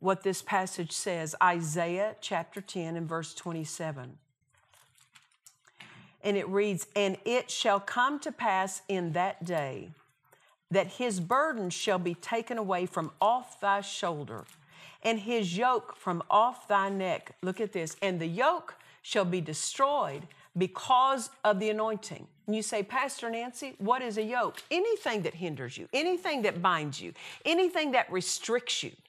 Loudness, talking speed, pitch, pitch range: -30 LUFS, 155 wpm, 200 Hz, 175-240 Hz